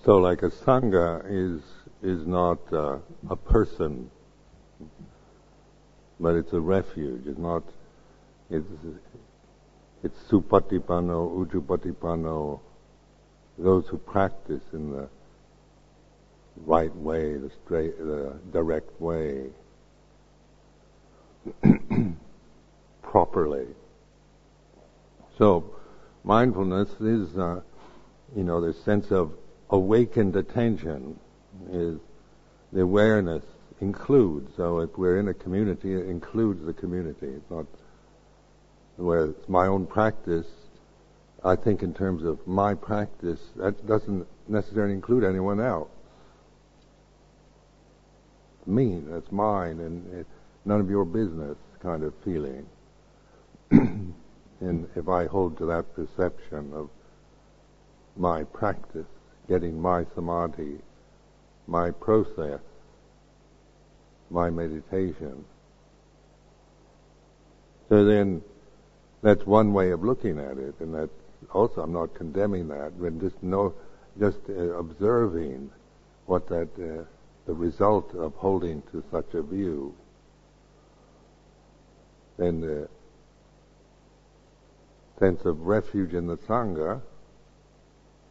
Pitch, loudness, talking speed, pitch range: 90 Hz, -27 LUFS, 100 wpm, 80-100 Hz